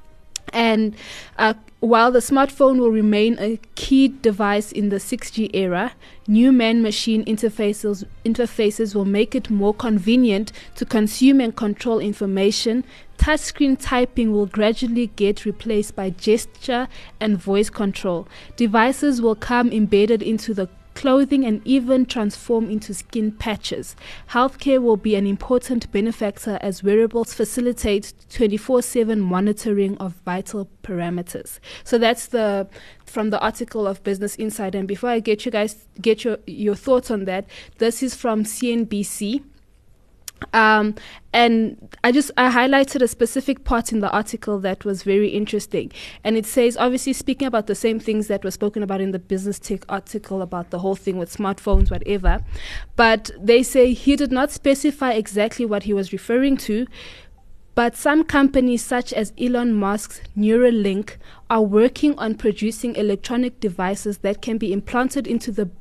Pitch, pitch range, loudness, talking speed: 220 Hz, 205-245 Hz, -20 LUFS, 155 wpm